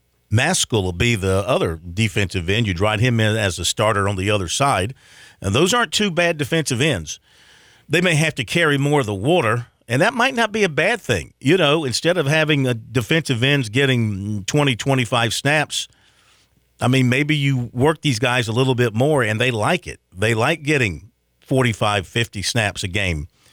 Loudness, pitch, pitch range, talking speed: -19 LUFS, 125 Hz, 105-150 Hz, 195 wpm